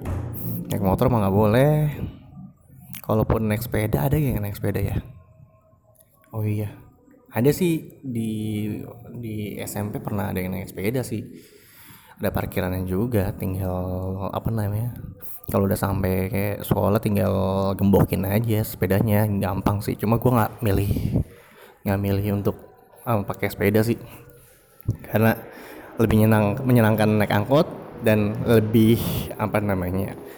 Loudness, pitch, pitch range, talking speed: -23 LUFS, 105 Hz, 100-115 Hz, 125 wpm